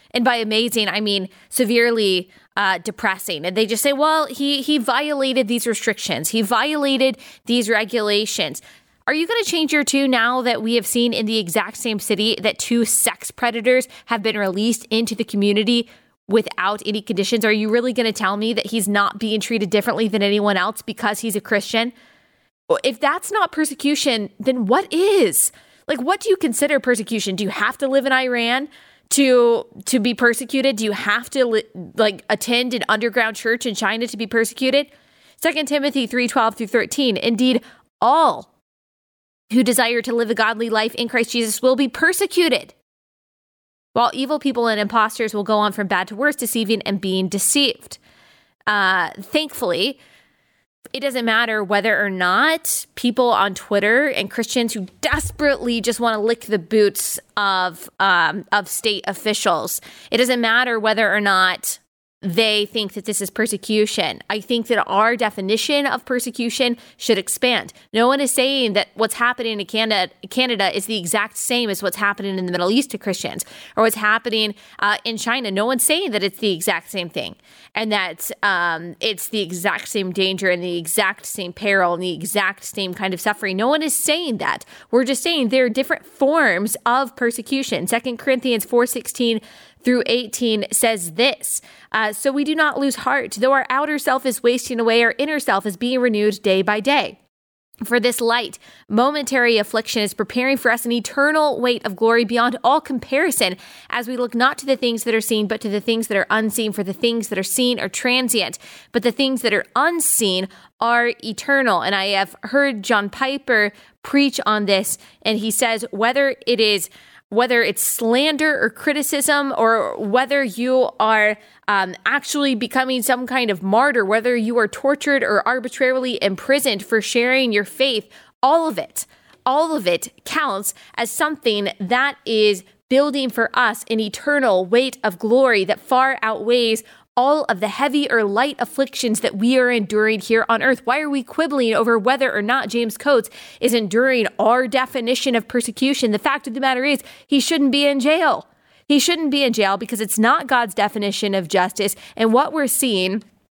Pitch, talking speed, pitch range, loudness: 235 Hz, 185 wpm, 210-260 Hz, -19 LUFS